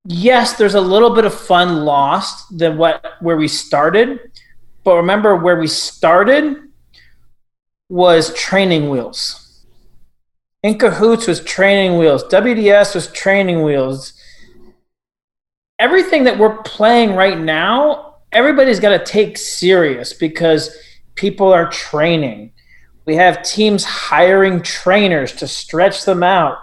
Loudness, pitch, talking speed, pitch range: -13 LUFS, 185 Hz, 120 wpm, 160-215 Hz